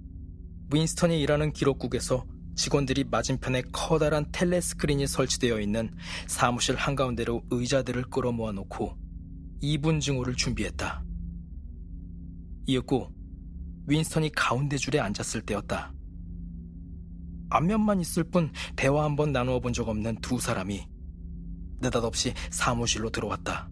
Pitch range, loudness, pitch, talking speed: 85-140 Hz, -28 LUFS, 115 Hz, 285 characters per minute